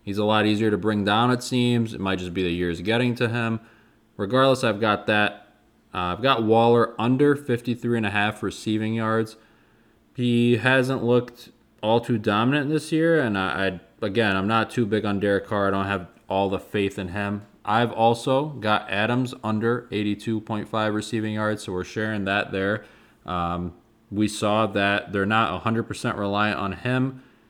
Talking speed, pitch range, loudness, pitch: 180 wpm, 100-120 Hz, -23 LUFS, 110 Hz